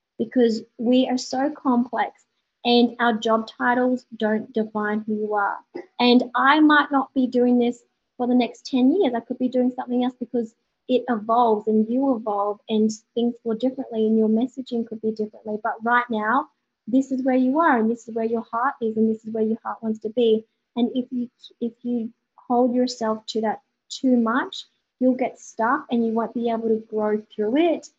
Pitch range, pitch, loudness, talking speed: 220-255 Hz, 240 Hz, -22 LUFS, 205 wpm